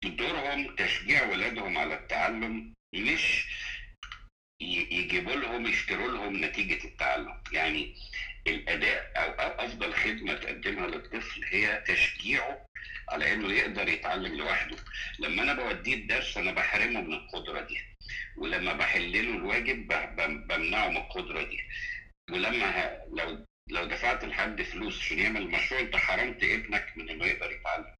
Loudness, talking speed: -30 LUFS, 125 wpm